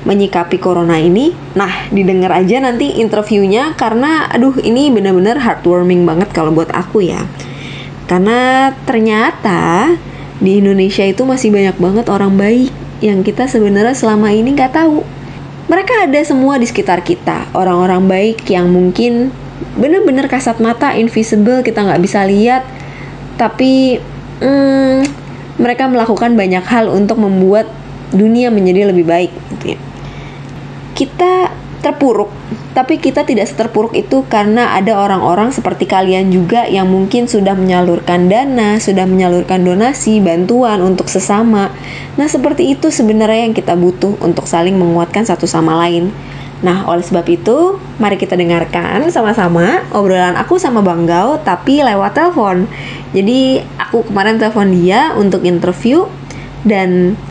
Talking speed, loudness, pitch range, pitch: 135 wpm, -11 LUFS, 185-245 Hz, 205 Hz